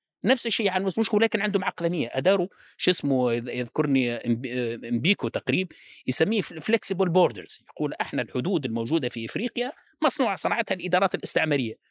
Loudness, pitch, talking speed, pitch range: -25 LUFS, 180 Hz, 135 wpm, 125-205 Hz